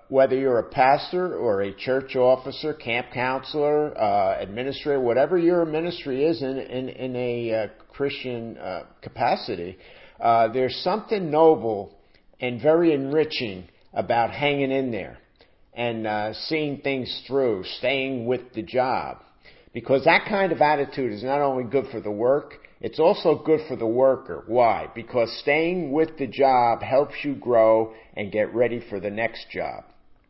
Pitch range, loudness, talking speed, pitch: 115-145 Hz, -23 LUFS, 155 wpm, 130 Hz